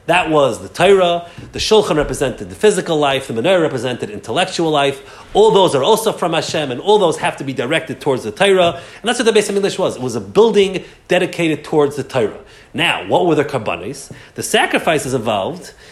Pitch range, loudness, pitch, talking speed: 140-200 Hz, -16 LUFS, 170 Hz, 205 wpm